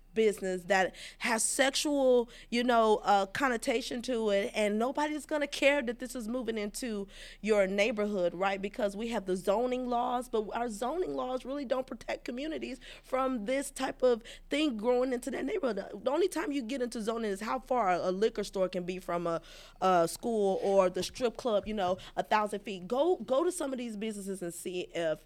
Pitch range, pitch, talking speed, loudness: 195-260 Hz, 230 Hz, 195 wpm, -31 LUFS